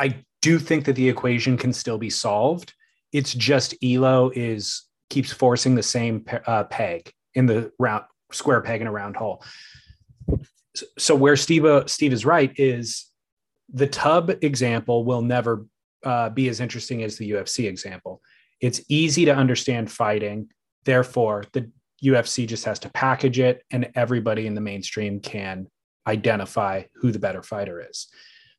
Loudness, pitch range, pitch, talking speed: -22 LUFS, 115-135 Hz, 125 Hz, 160 wpm